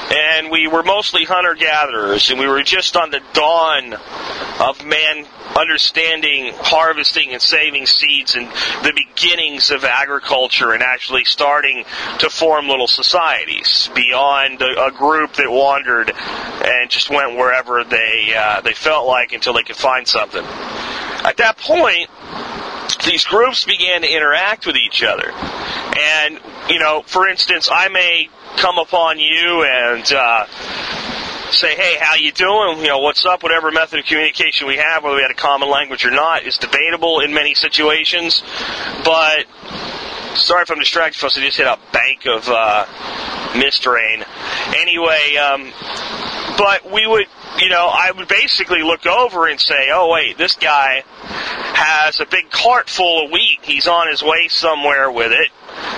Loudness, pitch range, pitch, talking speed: -13 LUFS, 140-170 Hz, 155 Hz, 160 wpm